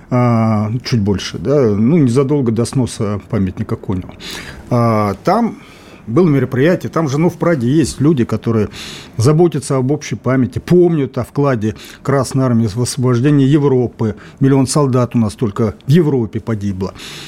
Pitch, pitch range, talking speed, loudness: 125 Hz, 110-140 Hz, 145 wpm, -15 LUFS